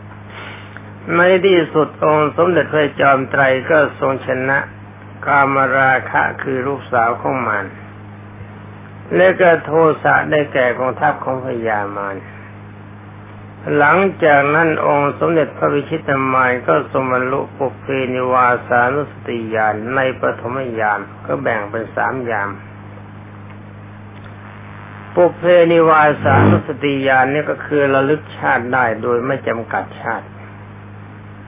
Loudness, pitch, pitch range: -15 LUFS, 120 Hz, 105-140 Hz